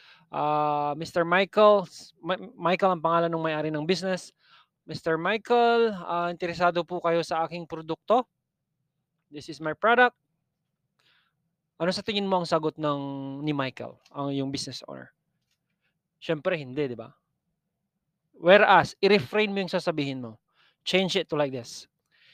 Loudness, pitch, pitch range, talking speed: -25 LUFS, 165 Hz, 150-185 Hz, 135 wpm